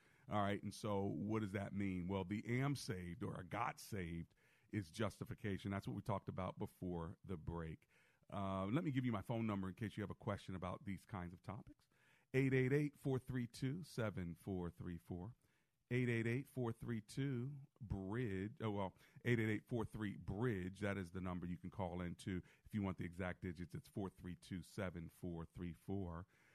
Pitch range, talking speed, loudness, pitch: 90-120 Hz, 165 wpm, -45 LUFS, 100 Hz